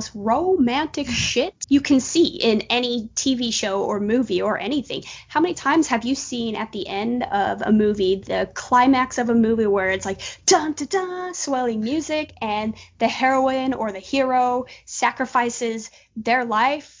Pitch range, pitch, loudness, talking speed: 220-280 Hz, 245 Hz, -21 LUFS, 170 wpm